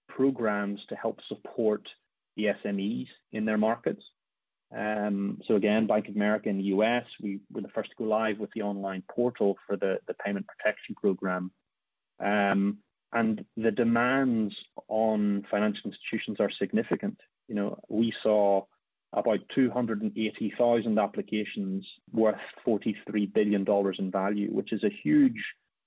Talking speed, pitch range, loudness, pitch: 140 wpm, 100-115 Hz, -29 LUFS, 105 Hz